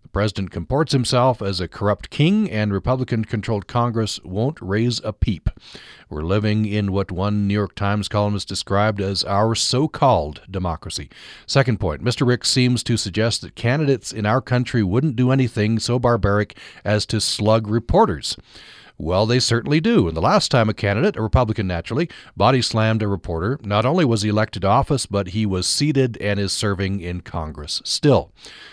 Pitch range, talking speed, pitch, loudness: 100-125 Hz, 180 wpm, 110 Hz, -20 LUFS